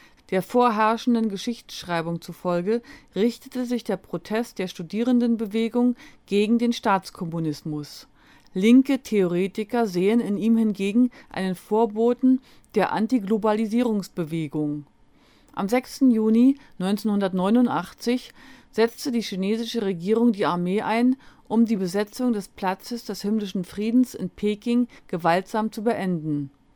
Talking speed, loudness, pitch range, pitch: 105 wpm, -24 LUFS, 190-240 Hz, 220 Hz